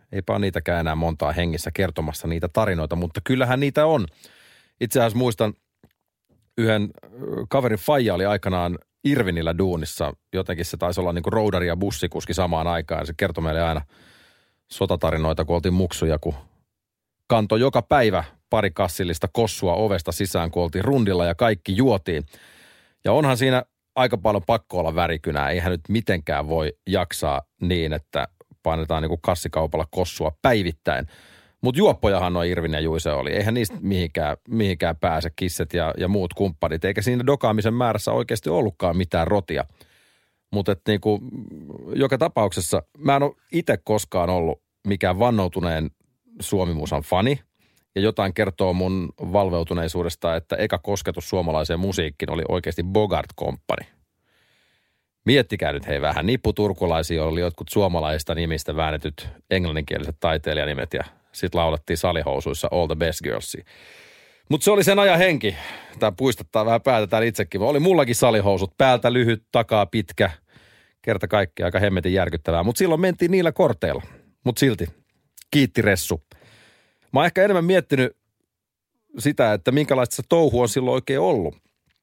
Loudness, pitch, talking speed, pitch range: -22 LUFS, 95 Hz, 145 wpm, 85-115 Hz